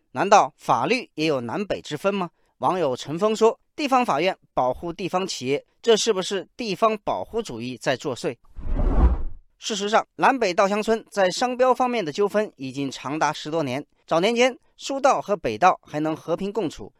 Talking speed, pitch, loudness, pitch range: 270 characters per minute, 190 Hz, -23 LUFS, 150-225 Hz